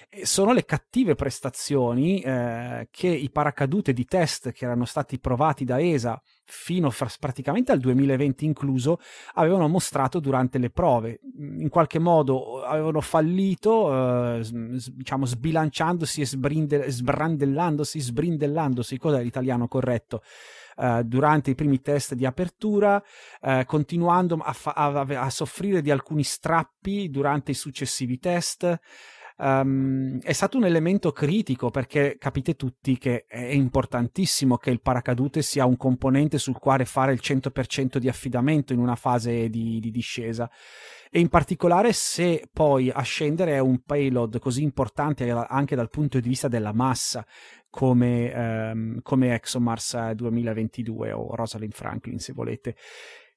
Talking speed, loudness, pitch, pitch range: 140 wpm, -24 LUFS, 135 Hz, 125-155 Hz